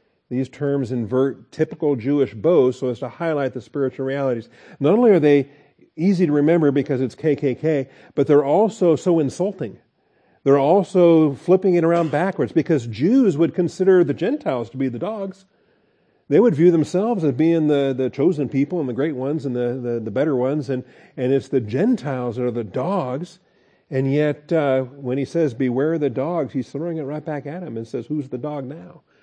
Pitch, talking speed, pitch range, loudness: 145 Hz, 195 wpm, 130-170 Hz, -20 LUFS